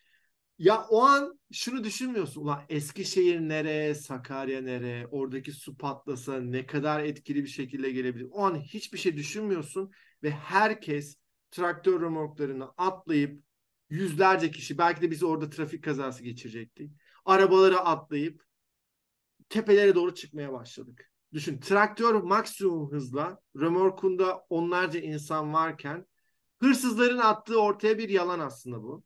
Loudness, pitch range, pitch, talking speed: -28 LUFS, 145-190 Hz, 160 Hz, 120 wpm